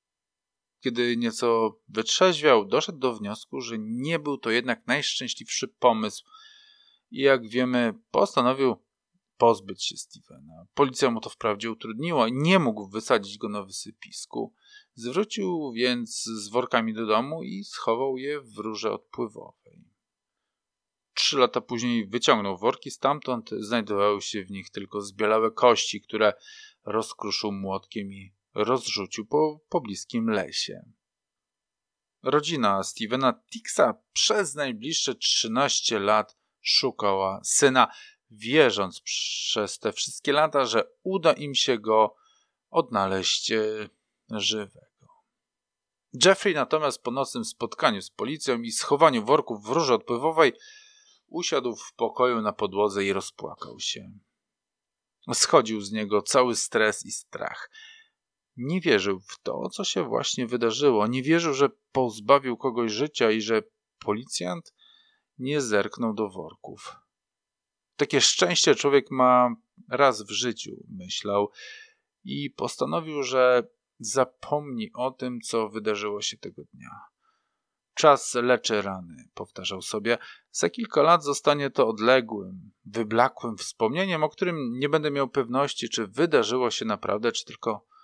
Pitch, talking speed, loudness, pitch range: 125 Hz, 120 wpm, -25 LUFS, 110-160 Hz